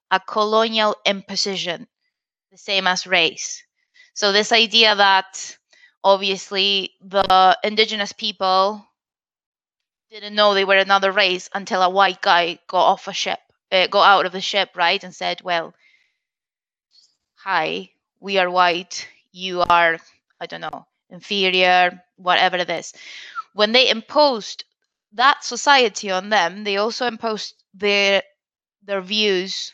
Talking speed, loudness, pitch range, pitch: 130 wpm, -18 LUFS, 185-215 Hz, 195 Hz